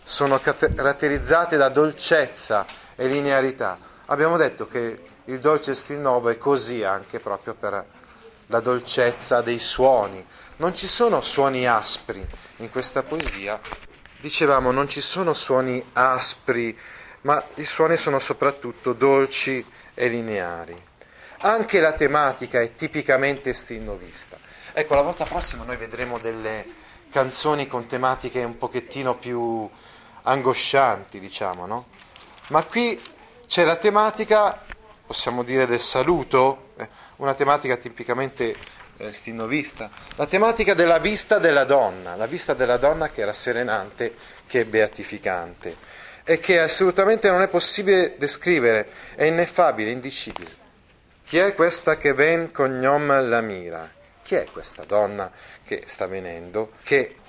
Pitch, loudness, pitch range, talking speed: 130 Hz, -21 LUFS, 120-155 Hz, 130 wpm